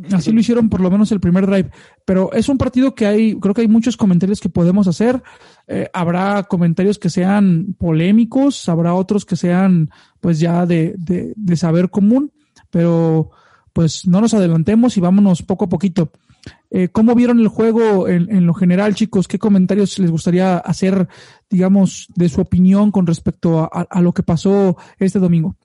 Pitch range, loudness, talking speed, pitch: 175-210 Hz, -15 LUFS, 185 wpm, 190 Hz